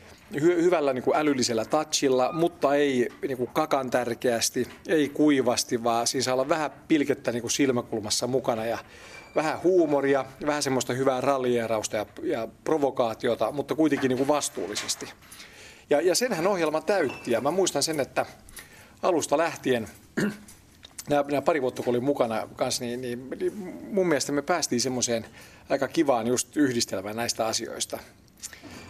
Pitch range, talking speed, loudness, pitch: 120-150 Hz, 145 wpm, -26 LUFS, 135 Hz